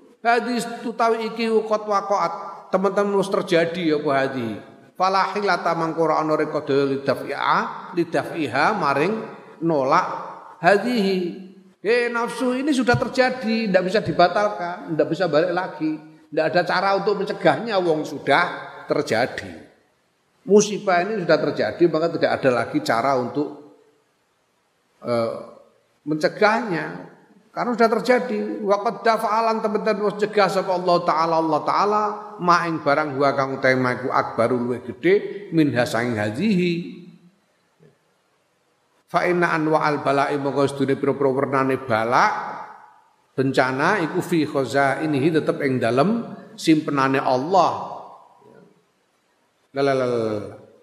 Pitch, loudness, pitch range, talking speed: 175 Hz, -21 LUFS, 140-210 Hz, 125 wpm